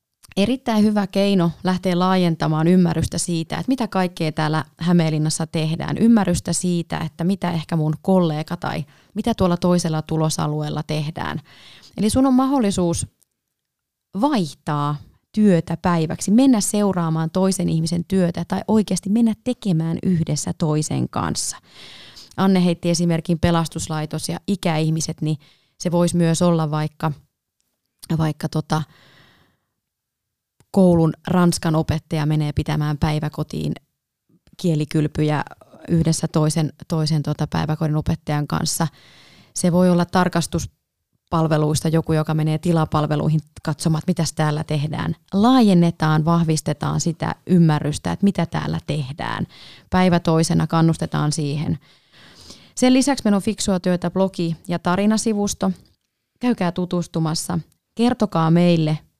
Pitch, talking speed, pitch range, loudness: 165 Hz, 110 wpm, 155-180 Hz, -20 LUFS